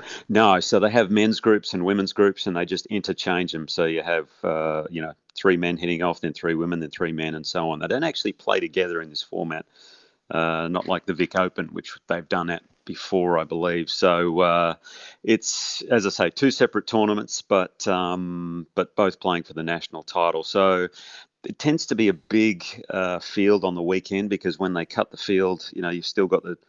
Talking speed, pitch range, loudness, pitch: 215 wpm, 85-100 Hz, -23 LUFS, 90 Hz